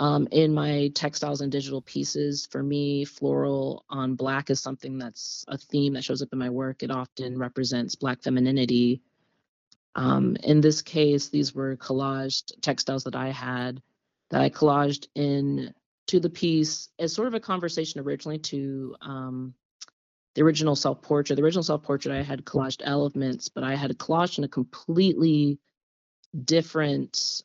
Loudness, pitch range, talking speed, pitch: -26 LUFS, 130-150 Hz, 160 wpm, 140 Hz